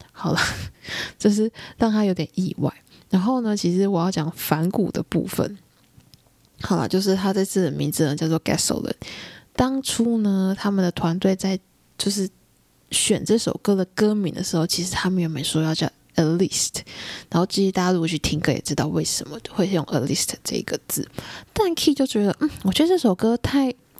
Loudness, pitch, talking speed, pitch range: -22 LUFS, 190 Hz, 320 characters per minute, 170-215 Hz